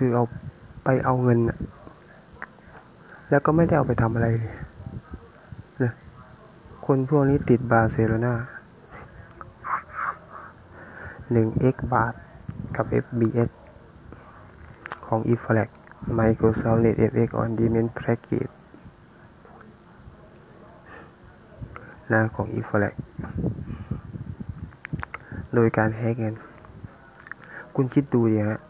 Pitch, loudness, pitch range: 115 Hz, -24 LUFS, 110-125 Hz